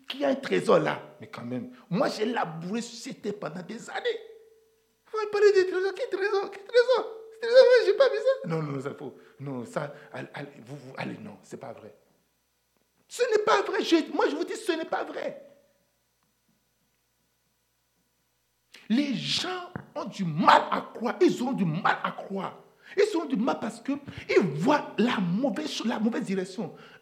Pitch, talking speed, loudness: 280 Hz, 185 wpm, -27 LUFS